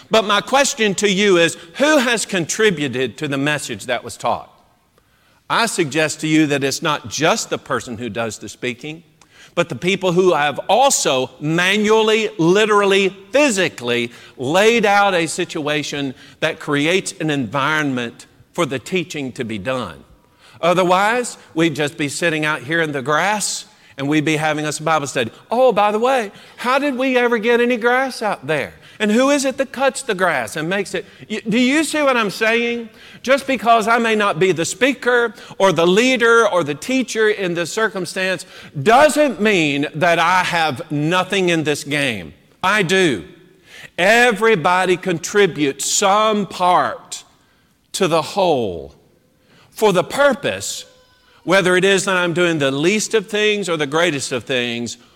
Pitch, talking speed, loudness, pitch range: 185 Hz, 165 wpm, -17 LUFS, 150-220 Hz